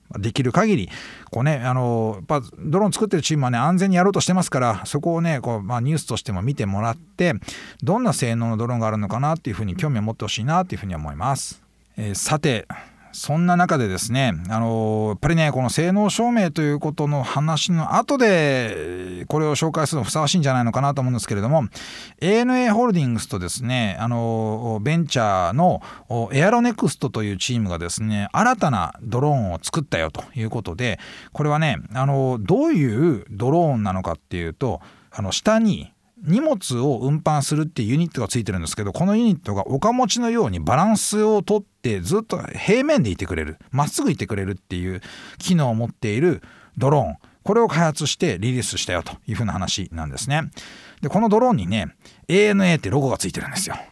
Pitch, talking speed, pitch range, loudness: 140 Hz, 430 characters per minute, 110-170 Hz, -21 LUFS